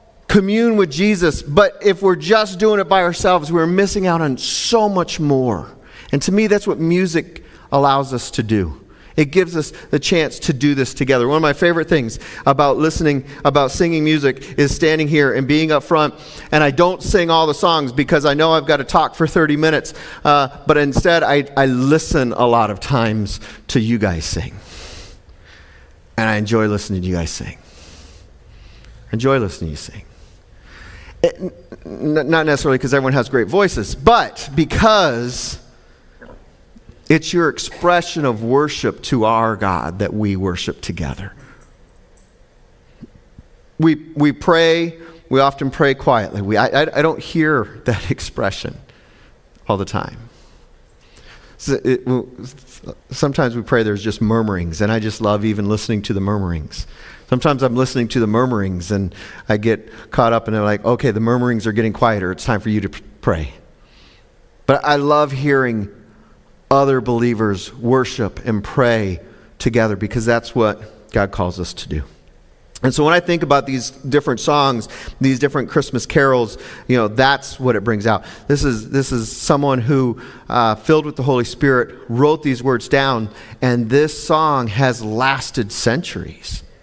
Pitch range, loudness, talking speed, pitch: 110-150 Hz, -17 LUFS, 165 wpm, 130 Hz